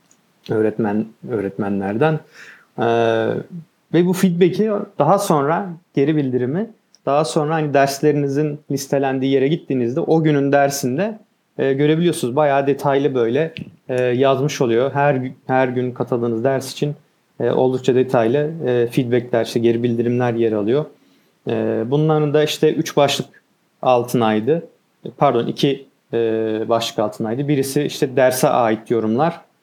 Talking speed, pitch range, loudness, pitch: 125 wpm, 120-155 Hz, -18 LUFS, 140 Hz